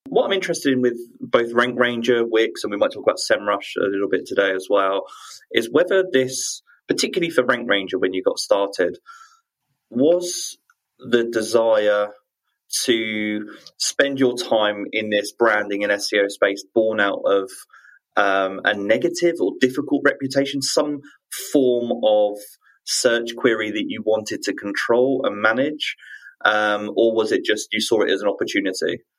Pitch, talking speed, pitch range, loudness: 120 Hz, 160 wpm, 105-165 Hz, -20 LUFS